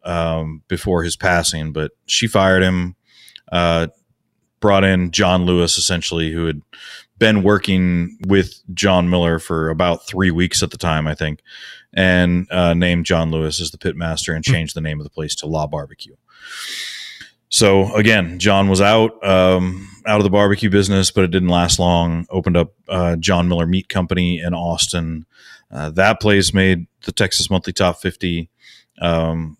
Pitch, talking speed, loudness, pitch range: 90 Hz, 170 wpm, -17 LUFS, 85-95 Hz